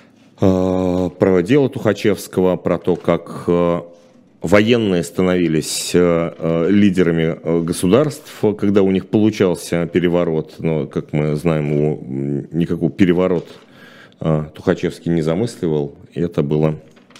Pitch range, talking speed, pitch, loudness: 80-95 Hz, 100 wpm, 85 Hz, -17 LUFS